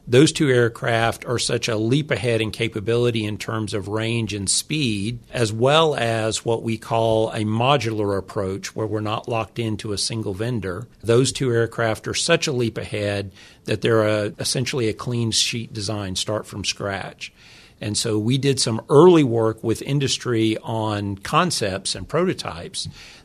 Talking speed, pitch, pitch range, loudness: 170 wpm, 115 Hz, 110-120 Hz, -21 LUFS